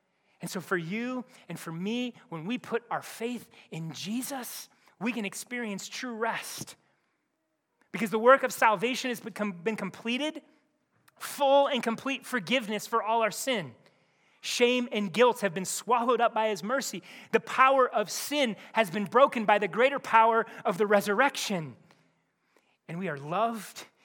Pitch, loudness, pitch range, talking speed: 230 Hz, -28 LUFS, 205-255 Hz, 155 wpm